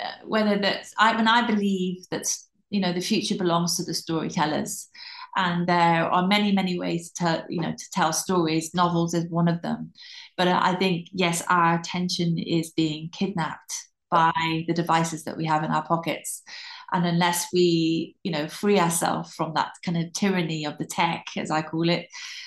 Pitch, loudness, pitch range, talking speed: 175 Hz, -24 LUFS, 165-195 Hz, 185 wpm